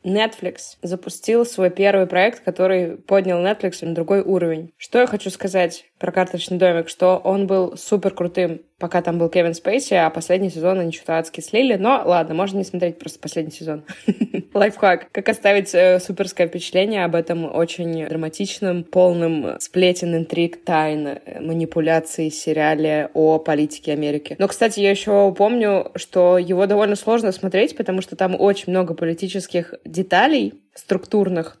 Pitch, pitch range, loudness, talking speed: 180 Hz, 165-195 Hz, -19 LUFS, 155 wpm